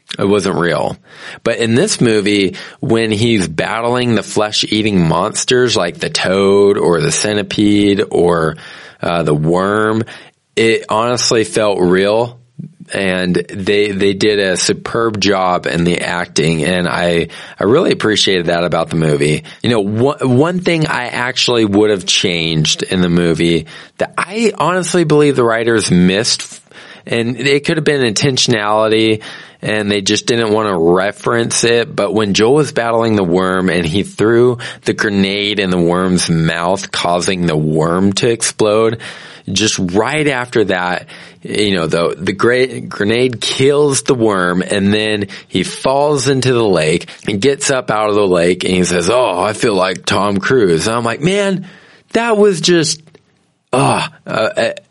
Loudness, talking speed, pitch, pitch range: -13 LUFS, 160 wpm, 105 Hz, 90-125 Hz